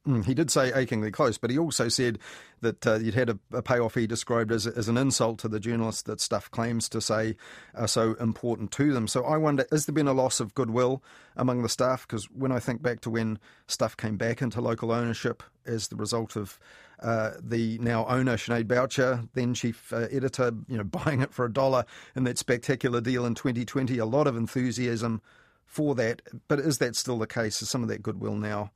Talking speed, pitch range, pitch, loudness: 225 wpm, 115-130 Hz, 120 Hz, -28 LUFS